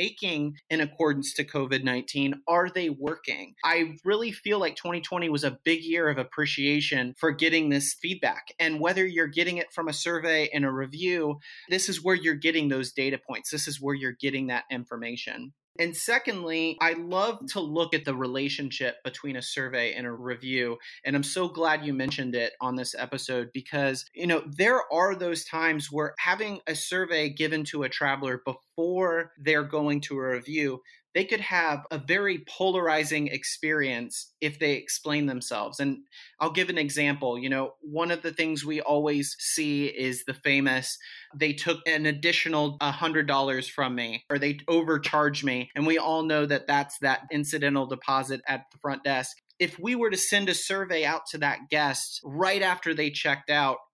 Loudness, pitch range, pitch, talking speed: -27 LUFS, 135-165 Hz, 150 Hz, 180 wpm